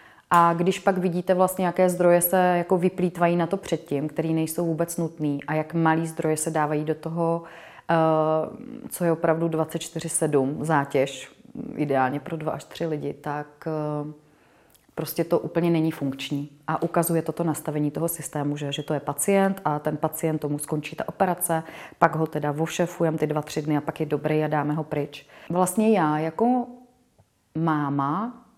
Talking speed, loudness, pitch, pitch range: 170 wpm, -25 LUFS, 160 Hz, 150-170 Hz